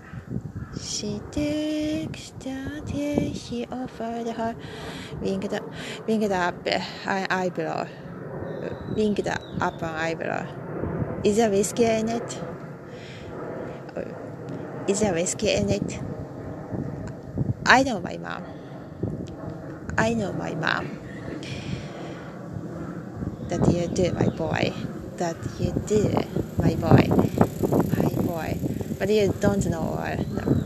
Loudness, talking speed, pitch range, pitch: -27 LUFS, 110 wpm, 160-220 Hz, 175 Hz